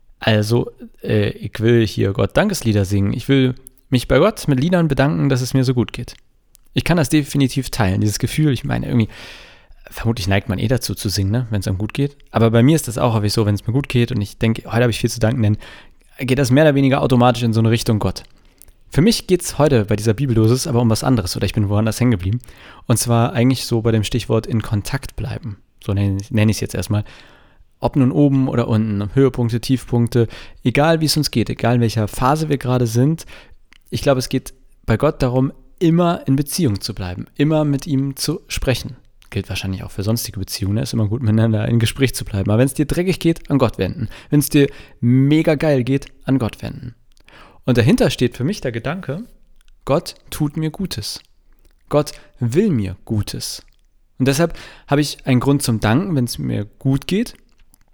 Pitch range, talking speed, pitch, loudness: 110-140 Hz, 215 wpm, 125 Hz, -18 LUFS